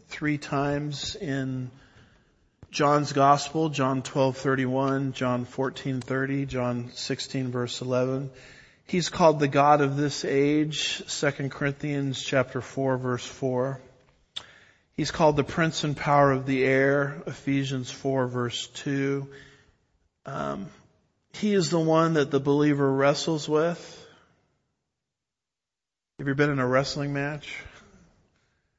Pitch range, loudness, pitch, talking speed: 130-145 Hz, -26 LUFS, 135 Hz, 115 wpm